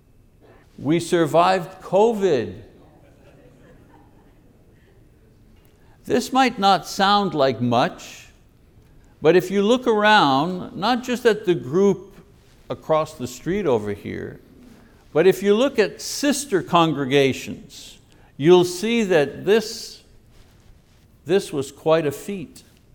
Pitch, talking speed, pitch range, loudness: 180 Hz, 105 wpm, 135-205 Hz, -20 LUFS